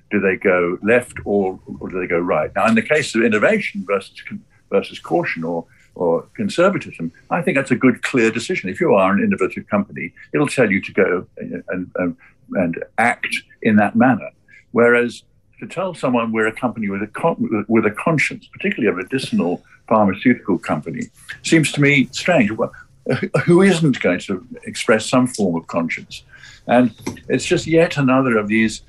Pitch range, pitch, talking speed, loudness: 105-145 Hz, 120 Hz, 175 wpm, -18 LUFS